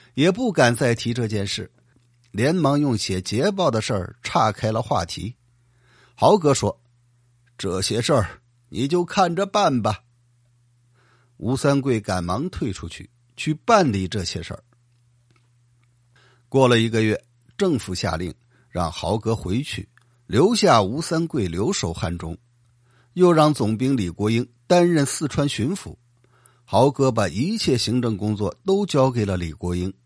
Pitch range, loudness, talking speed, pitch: 105-130 Hz, -21 LUFS, 205 characters per minute, 120 Hz